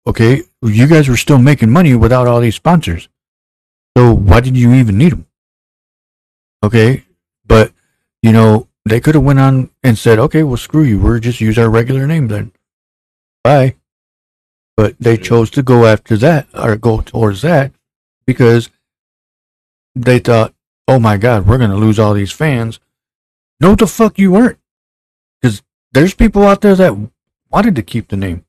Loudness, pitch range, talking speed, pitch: -10 LUFS, 105-135 Hz, 170 wpm, 115 Hz